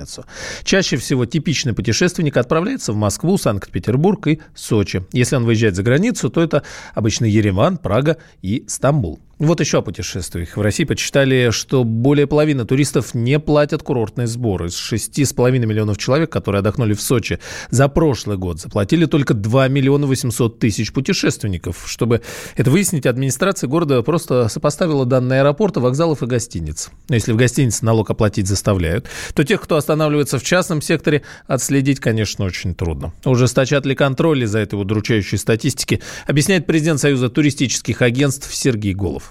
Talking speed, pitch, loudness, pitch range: 155 wpm, 130 Hz, -17 LUFS, 110-150 Hz